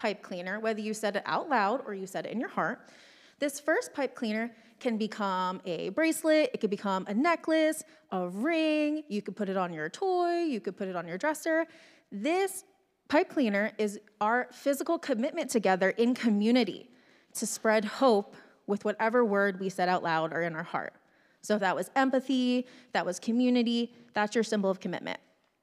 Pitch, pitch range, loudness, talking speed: 230 Hz, 200-290 Hz, -30 LUFS, 190 wpm